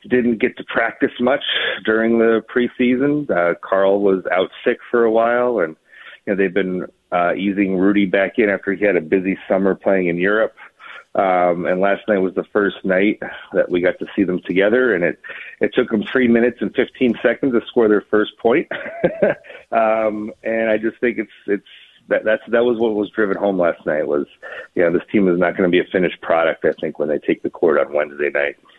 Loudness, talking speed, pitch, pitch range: -18 LUFS, 215 wpm, 100 Hz, 95-115 Hz